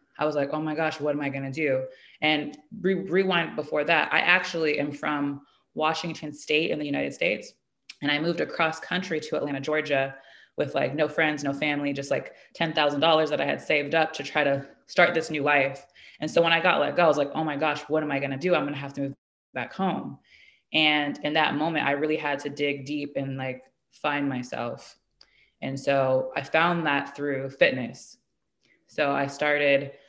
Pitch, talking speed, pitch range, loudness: 150 Hz, 215 wpm, 140-155 Hz, -26 LUFS